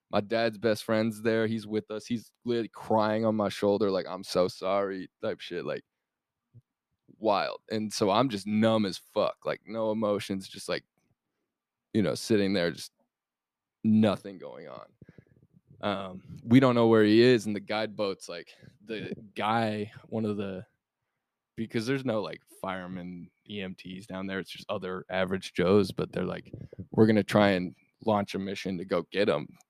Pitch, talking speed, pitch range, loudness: 105 Hz, 175 wpm, 95-110 Hz, -29 LUFS